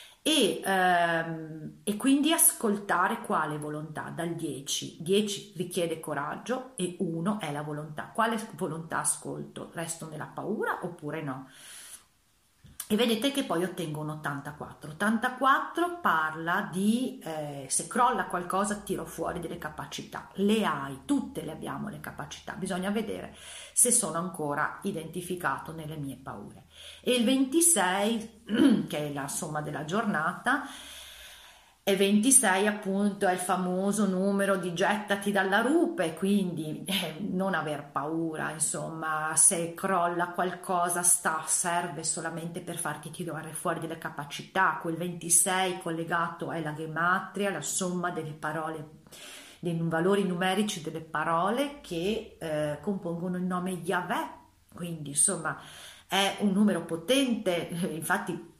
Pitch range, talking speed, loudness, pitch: 160-200 Hz, 125 wpm, -28 LUFS, 180 Hz